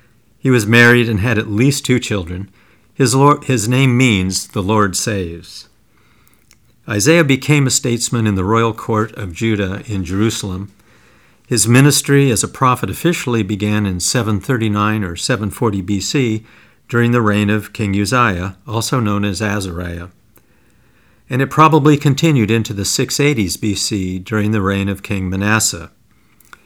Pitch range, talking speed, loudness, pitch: 100-125 Hz, 145 wpm, -15 LUFS, 110 Hz